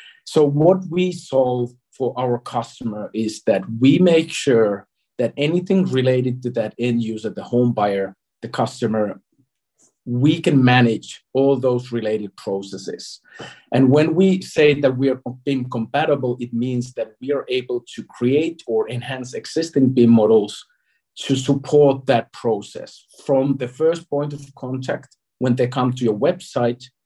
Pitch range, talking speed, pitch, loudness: 115-140 Hz, 155 wpm, 125 Hz, -19 LUFS